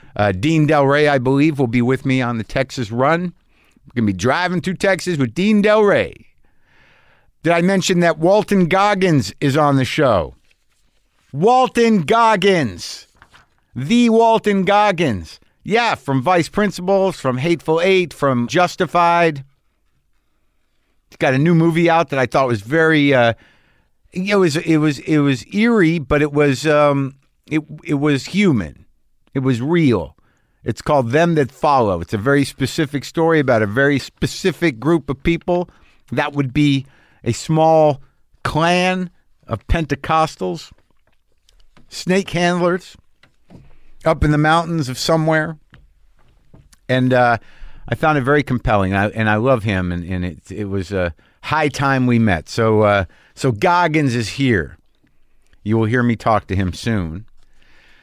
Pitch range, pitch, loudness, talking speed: 120-170 Hz, 145 Hz, -17 LUFS, 155 wpm